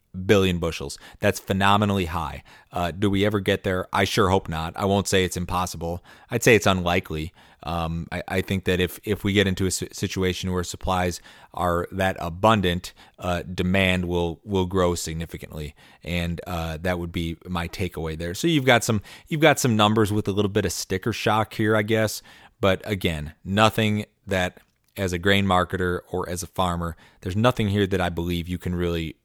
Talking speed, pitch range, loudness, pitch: 190 wpm, 85-100 Hz, -24 LUFS, 90 Hz